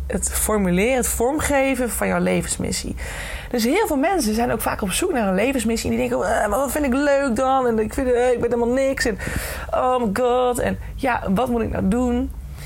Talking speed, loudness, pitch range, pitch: 220 wpm, -21 LUFS, 230-265 Hz, 245 Hz